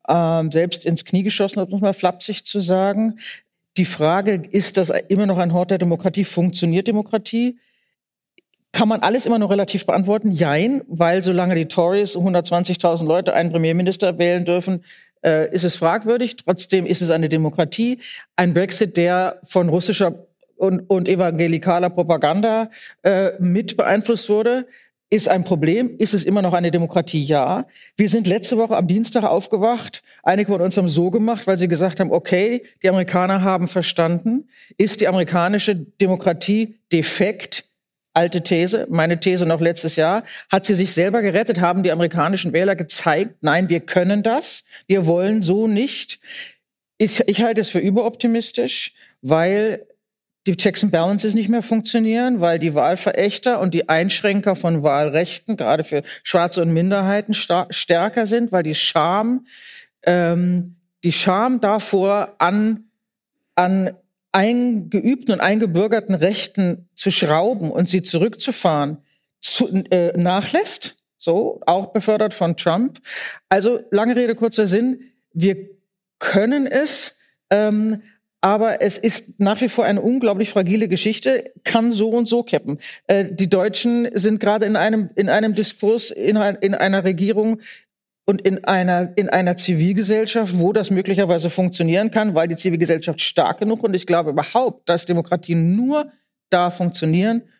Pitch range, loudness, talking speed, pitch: 175-220 Hz, -18 LUFS, 150 wpm, 195 Hz